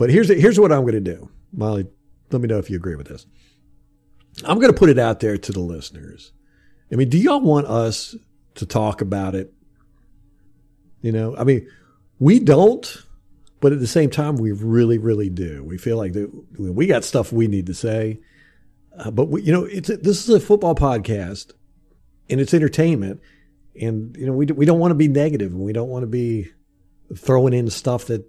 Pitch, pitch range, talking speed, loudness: 115 Hz, 100-145 Hz, 210 wpm, -18 LUFS